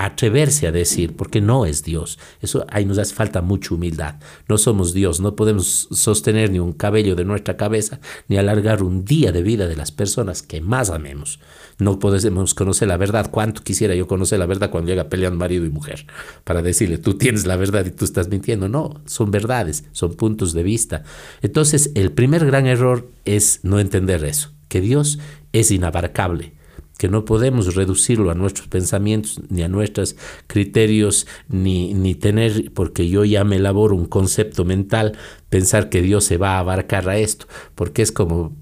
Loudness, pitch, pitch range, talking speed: -18 LUFS, 100 Hz, 90-110 Hz, 185 wpm